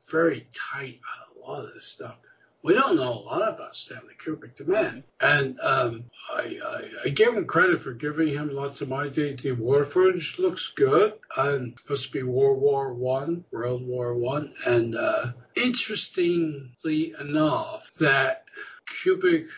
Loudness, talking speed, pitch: -25 LUFS, 160 wpm, 150 Hz